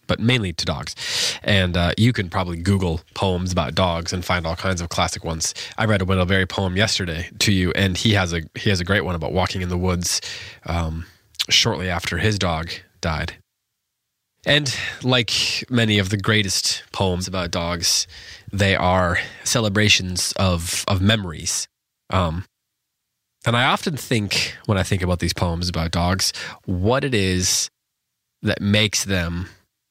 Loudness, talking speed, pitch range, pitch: -20 LUFS, 165 wpm, 90-105 Hz, 95 Hz